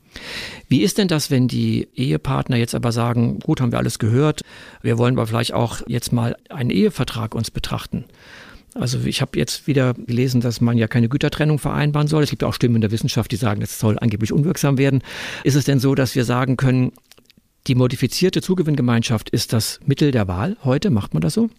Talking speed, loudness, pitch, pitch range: 210 wpm, -19 LUFS, 125 Hz, 115-145 Hz